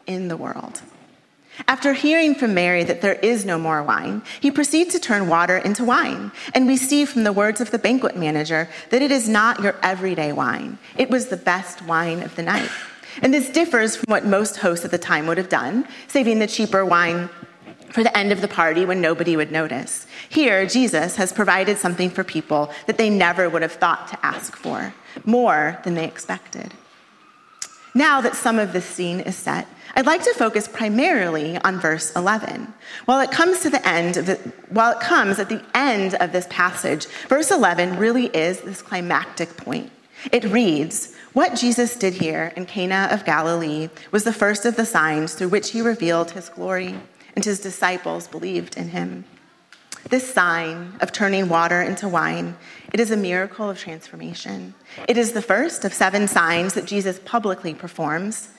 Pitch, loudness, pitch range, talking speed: 195 Hz, -20 LUFS, 170-235 Hz, 190 wpm